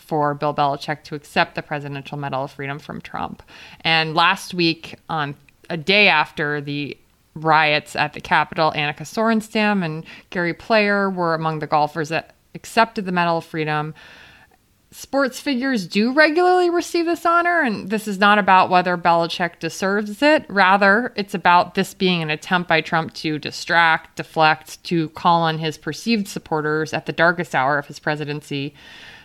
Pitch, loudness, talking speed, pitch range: 165 Hz, -19 LUFS, 165 wpm, 155-200 Hz